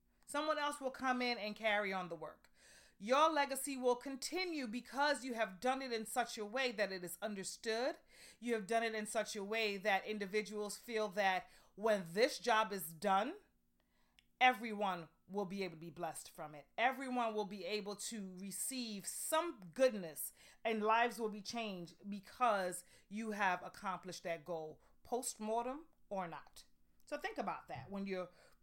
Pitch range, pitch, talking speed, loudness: 185-245 Hz, 210 Hz, 170 wpm, -39 LUFS